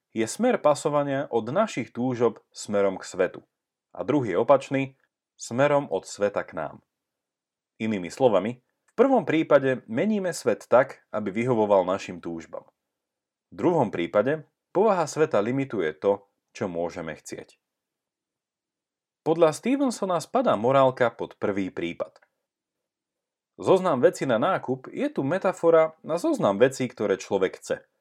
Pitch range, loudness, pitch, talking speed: 110-175 Hz, -25 LUFS, 135 Hz, 125 wpm